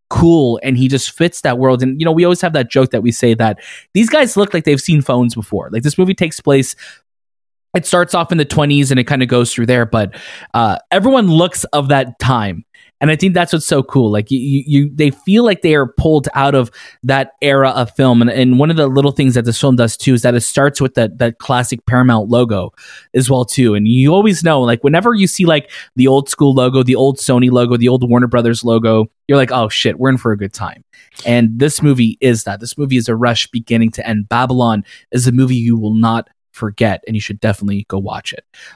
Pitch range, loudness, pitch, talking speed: 115-145 Hz, -13 LUFS, 130 Hz, 245 wpm